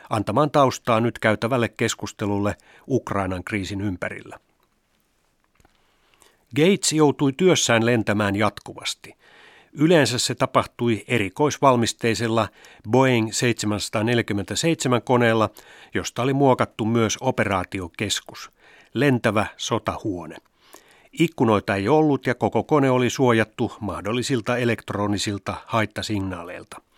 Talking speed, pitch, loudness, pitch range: 80 wpm, 115 Hz, -22 LUFS, 105-130 Hz